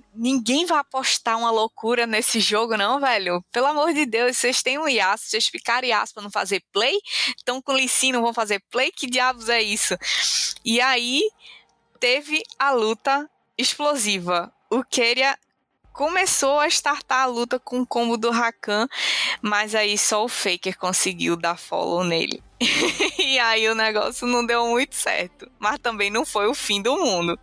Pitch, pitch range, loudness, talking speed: 240 Hz, 215-270 Hz, -21 LUFS, 170 wpm